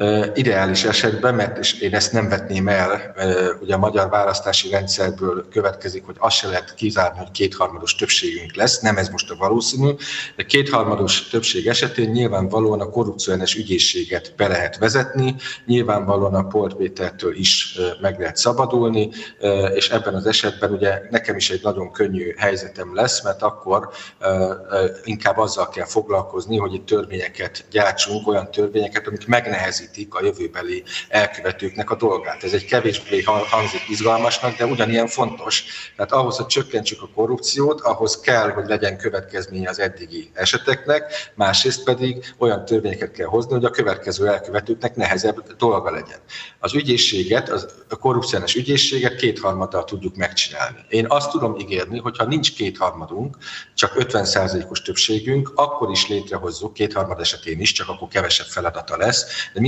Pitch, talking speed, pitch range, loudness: 110 Hz, 145 wpm, 100-130 Hz, -20 LUFS